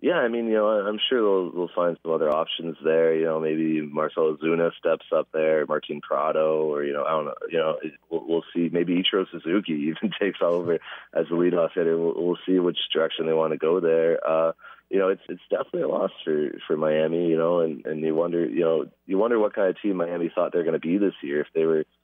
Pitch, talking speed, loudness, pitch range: 80 Hz, 250 wpm, -24 LUFS, 80-85 Hz